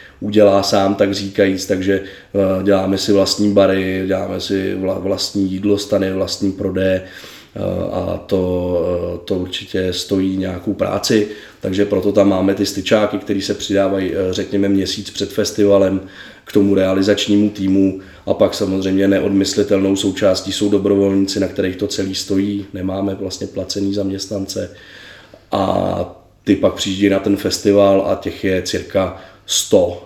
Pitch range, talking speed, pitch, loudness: 95-100 Hz, 135 wpm, 95 Hz, -17 LUFS